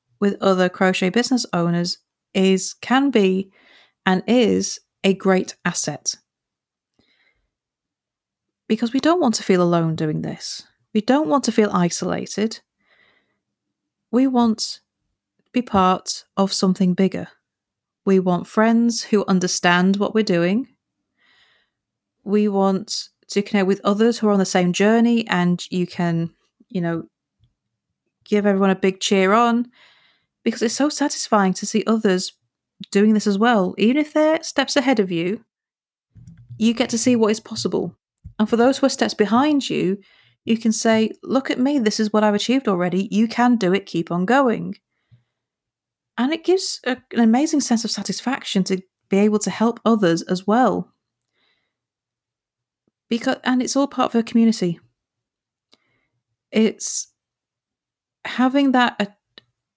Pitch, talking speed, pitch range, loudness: 210 Hz, 150 wpm, 185-235 Hz, -19 LUFS